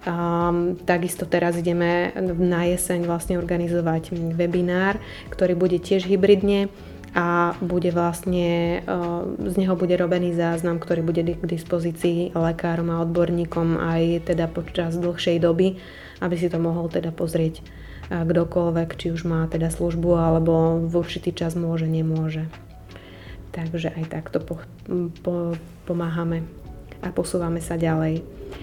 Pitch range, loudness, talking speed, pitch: 165-175 Hz, -23 LUFS, 130 wpm, 170 Hz